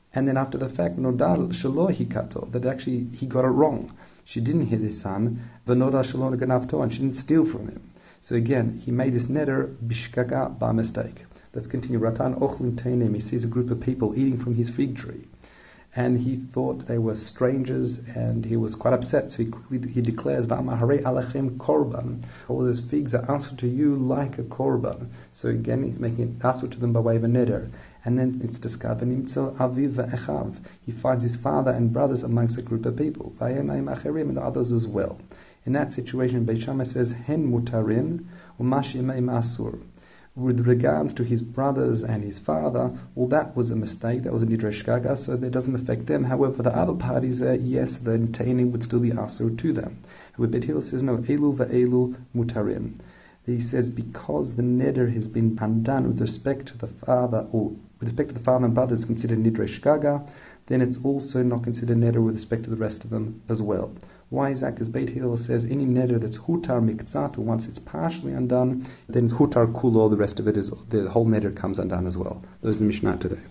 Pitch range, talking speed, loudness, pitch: 110-130 Hz, 190 wpm, -25 LUFS, 120 Hz